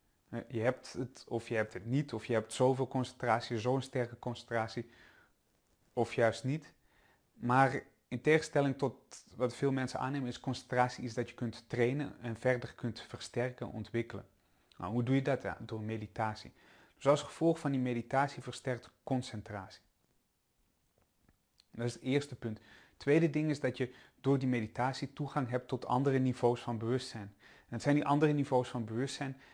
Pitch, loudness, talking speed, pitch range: 125 Hz, -35 LUFS, 170 wpm, 115-135 Hz